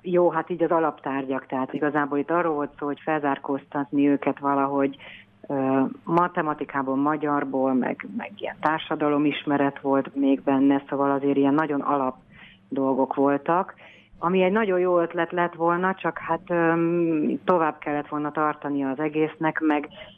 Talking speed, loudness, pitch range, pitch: 140 wpm, -24 LUFS, 140-165 Hz, 150 Hz